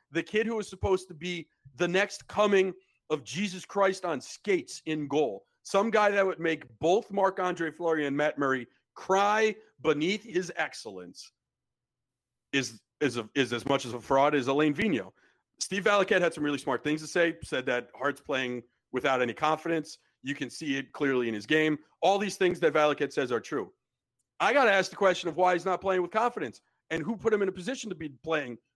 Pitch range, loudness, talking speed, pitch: 140-190 Hz, -29 LUFS, 205 wpm, 165 Hz